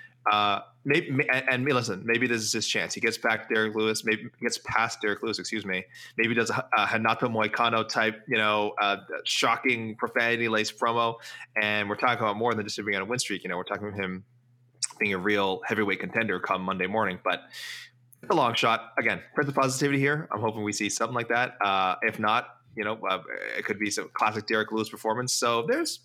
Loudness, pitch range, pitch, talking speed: -27 LUFS, 105-125 Hz, 110 Hz, 225 wpm